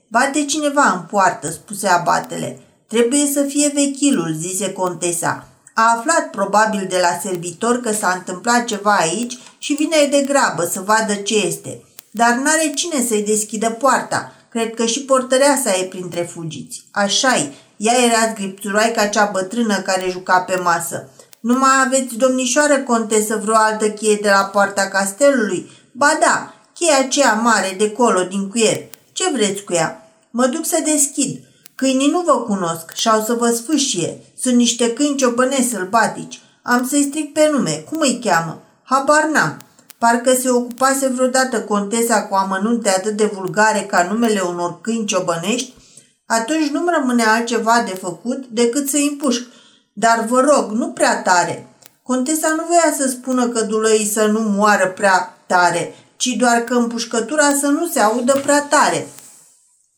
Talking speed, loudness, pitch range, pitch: 160 wpm, -17 LUFS, 200-265 Hz, 230 Hz